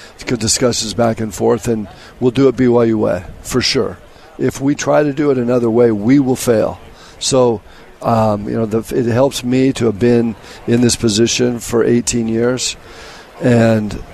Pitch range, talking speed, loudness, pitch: 115-125 Hz, 185 wpm, -15 LUFS, 120 Hz